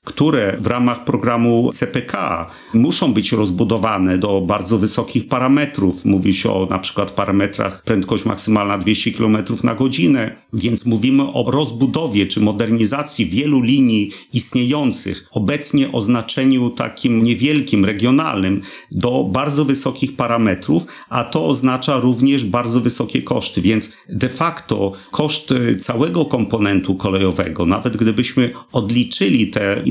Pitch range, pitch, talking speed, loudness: 105-130 Hz, 120 Hz, 120 wpm, -16 LUFS